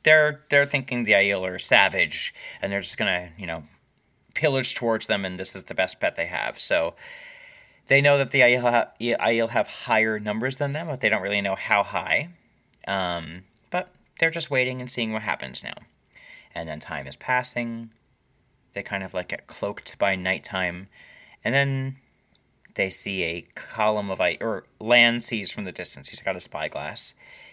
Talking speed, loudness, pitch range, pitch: 185 wpm, -24 LUFS, 95-135 Hz, 120 Hz